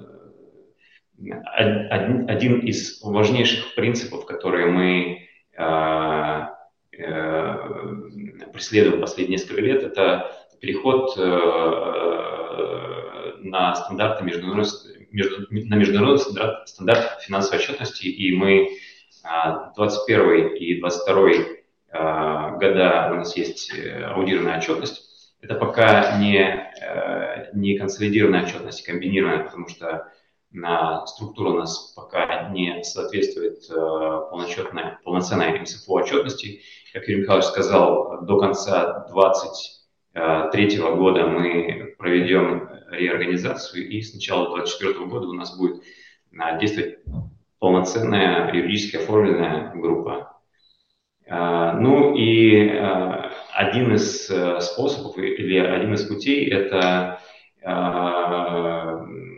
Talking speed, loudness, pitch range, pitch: 95 wpm, -21 LUFS, 85-105 Hz, 95 Hz